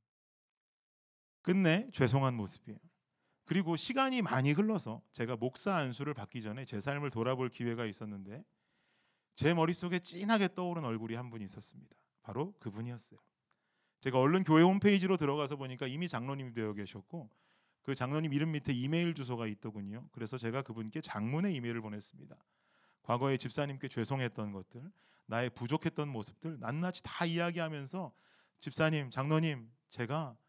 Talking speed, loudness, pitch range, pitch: 360 characters per minute, -35 LUFS, 115-165 Hz, 135 Hz